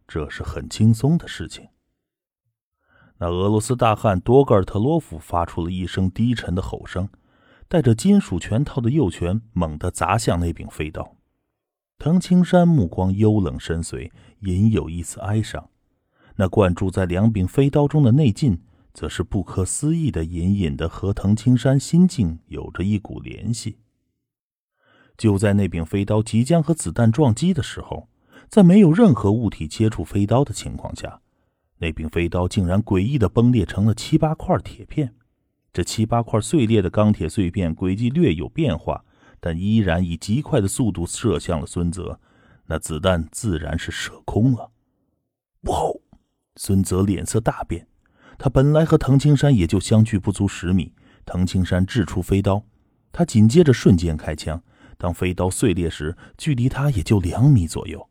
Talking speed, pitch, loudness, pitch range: 245 characters per minute, 105 Hz, -20 LUFS, 90-125 Hz